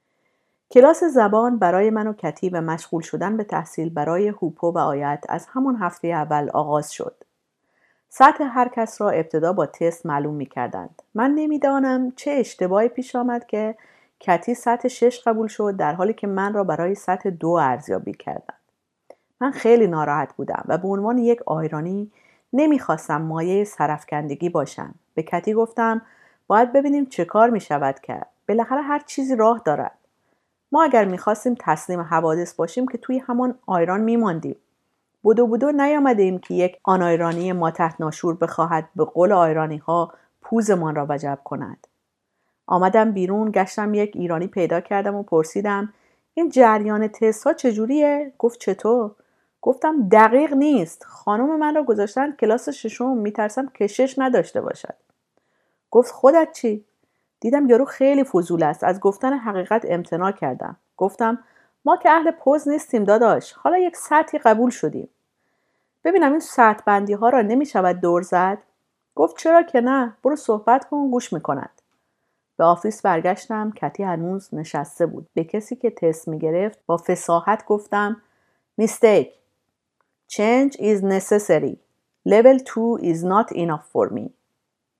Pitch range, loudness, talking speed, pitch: 170-250 Hz, -20 LUFS, 150 wpm, 210 Hz